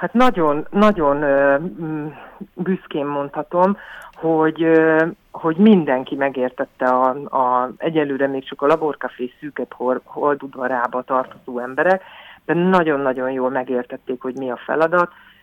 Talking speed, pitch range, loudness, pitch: 110 wpm, 130-160 Hz, -19 LUFS, 145 Hz